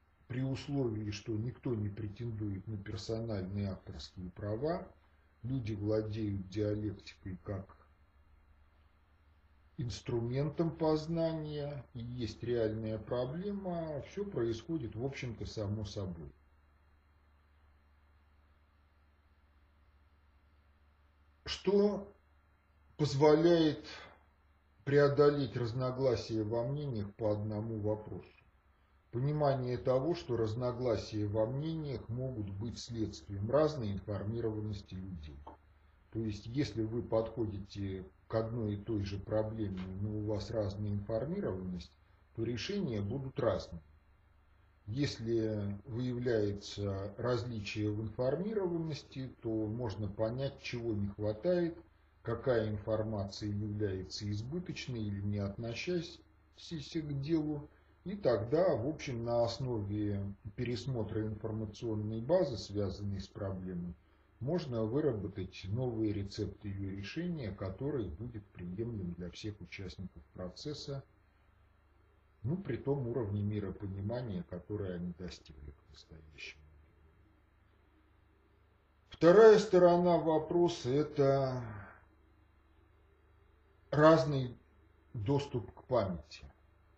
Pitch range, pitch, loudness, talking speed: 85-125 Hz, 105 Hz, -35 LUFS, 90 wpm